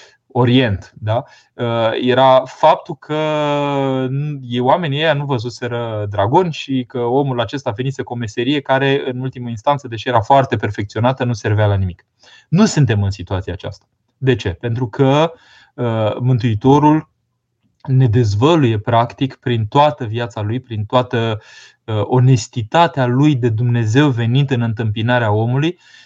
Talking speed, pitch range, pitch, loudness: 130 wpm, 115-135 Hz, 125 Hz, -16 LUFS